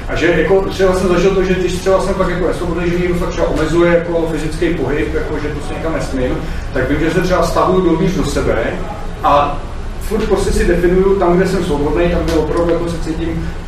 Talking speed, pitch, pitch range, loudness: 230 wpm, 175 Hz, 165-185 Hz, -15 LUFS